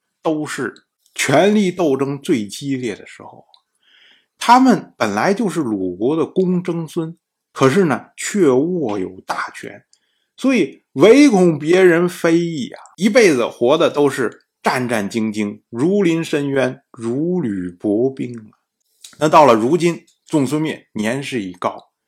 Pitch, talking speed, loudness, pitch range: 155 Hz, 200 characters per minute, -17 LUFS, 130-175 Hz